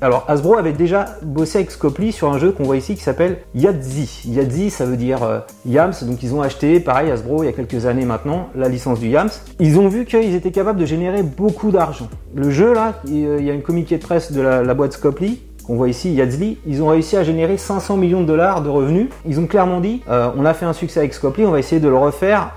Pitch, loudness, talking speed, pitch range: 155 Hz, -17 LUFS, 255 wpm, 135-190 Hz